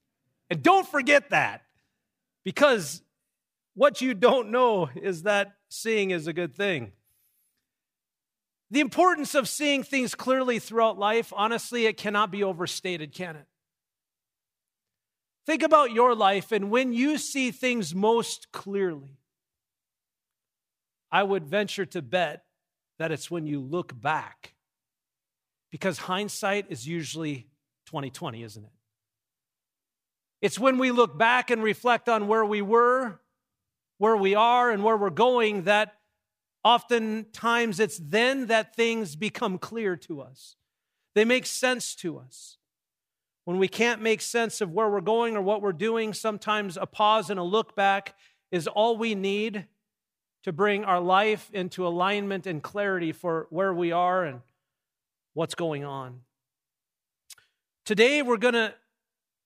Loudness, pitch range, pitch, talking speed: -25 LUFS, 175-230 Hz, 205 Hz, 140 wpm